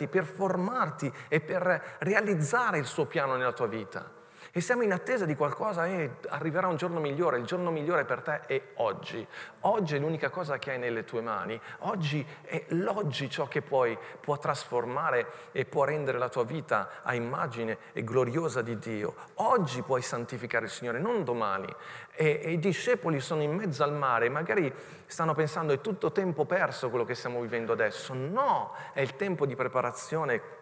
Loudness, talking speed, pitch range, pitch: -30 LUFS, 180 wpm, 135-180 Hz, 155 Hz